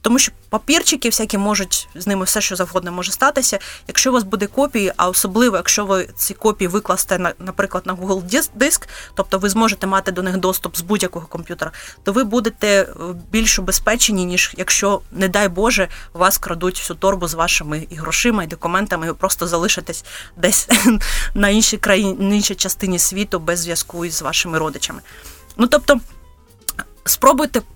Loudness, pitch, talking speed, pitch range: -17 LUFS, 195 Hz, 170 wpm, 180-220 Hz